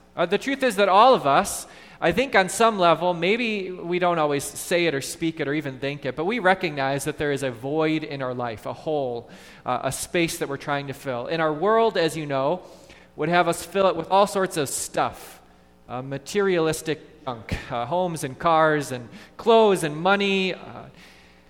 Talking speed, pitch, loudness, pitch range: 210 wpm, 155 Hz, -23 LUFS, 135-185 Hz